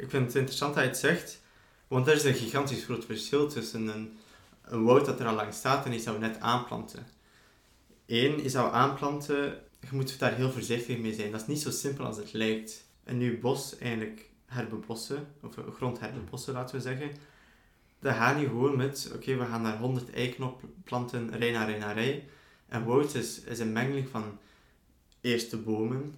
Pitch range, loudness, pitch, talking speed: 115-135 Hz, -31 LUFS, 125 Hz, 200 wpm